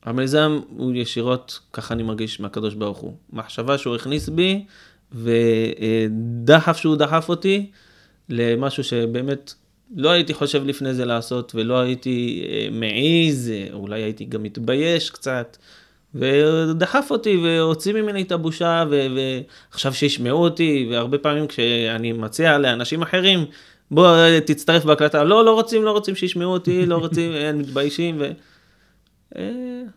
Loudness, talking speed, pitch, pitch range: -19 LUFS, 125 wpm, 145 Hz, 120-165 Hz